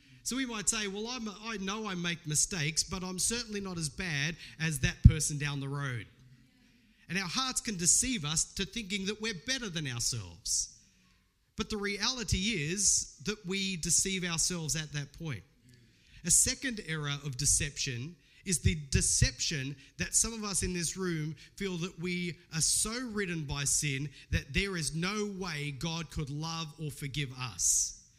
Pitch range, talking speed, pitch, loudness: 145-200 Hz, 170 wpm, 165 Hz, -31 LUFS